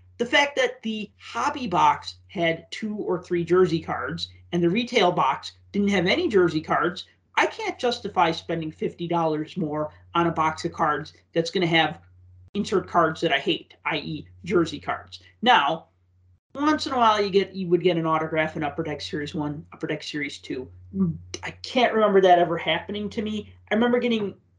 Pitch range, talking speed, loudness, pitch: 150-205 Hz, 185 wpm, -24 LUFS, 170 Hz